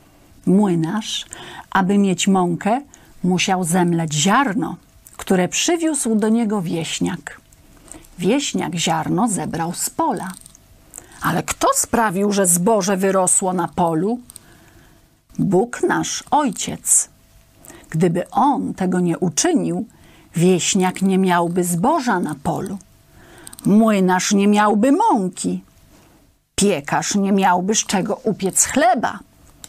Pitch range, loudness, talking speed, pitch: 175-220 Hz, -18 LUFS, 100 wpm, 190 Hz